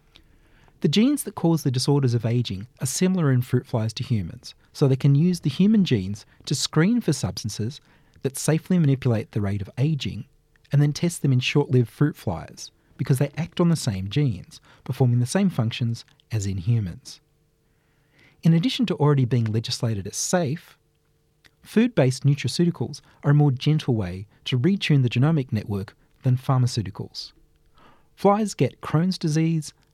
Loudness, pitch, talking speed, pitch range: -23 LUFS, 140 Hz, 165 wpm, 120-155 Hz